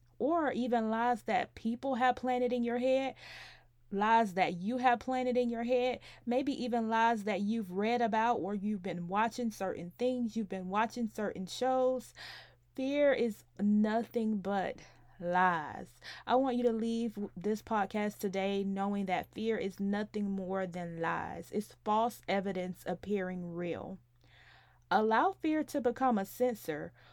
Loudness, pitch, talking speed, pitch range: -33 LUFS, 220 Hz, 150 wpm, 195-245 Hz